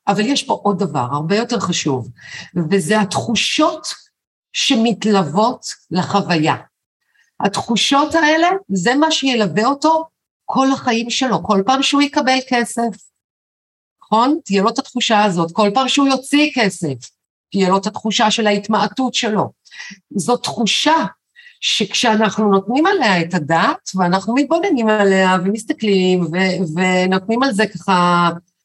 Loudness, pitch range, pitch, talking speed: -16 LUFS, 190-265 Hz, 215 Hz, 125 wpm